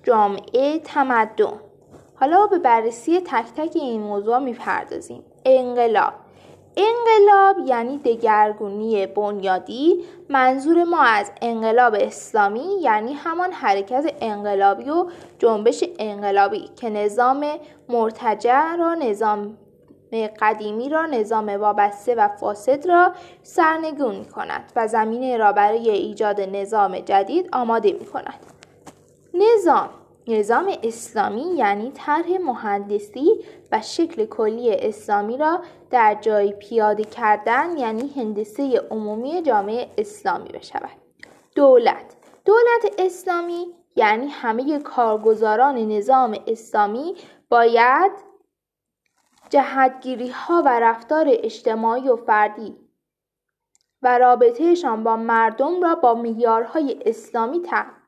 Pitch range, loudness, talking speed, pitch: 220-345 Hz, -19 LUFS, 100 wpm, 250 Hz